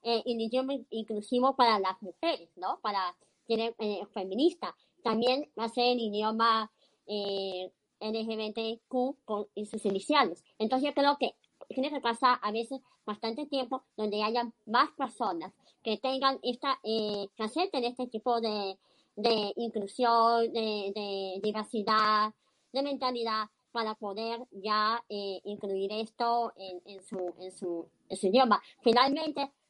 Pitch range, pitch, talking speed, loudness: 210-250 Hz, 225 Hz, 140 wpm, -31 LUFS